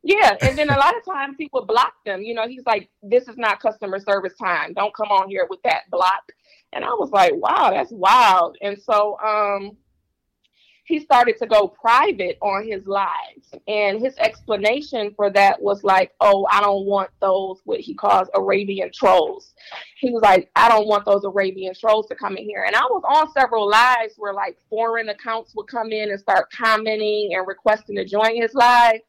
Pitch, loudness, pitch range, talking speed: 215 Hz, -19 LUFS, 200-245 Hz, 200 wpm